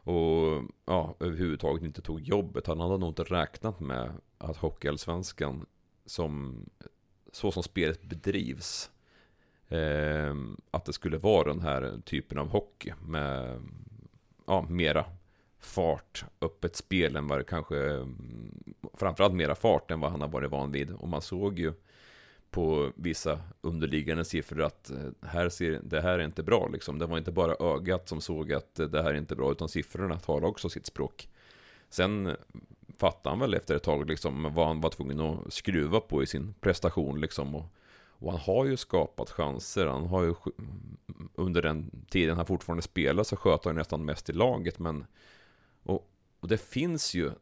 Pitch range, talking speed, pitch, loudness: 75-90 Hz, 165 wpm, 80 Hz, -31 LUFS